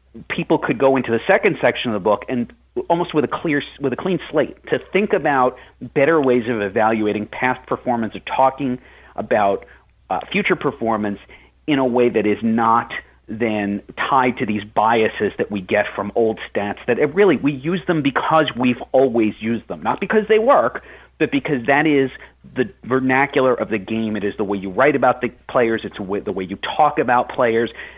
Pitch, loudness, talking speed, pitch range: 125 Hz, -19 LUFS, 195 wpm, 110-145 Hz